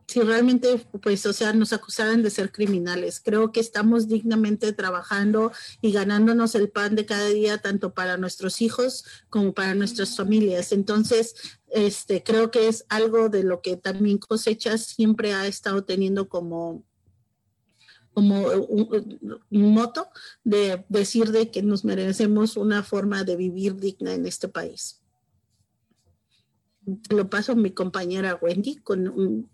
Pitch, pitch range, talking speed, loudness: 205 Hz, 190-220 Hz, 150 wpm, -23 LUFS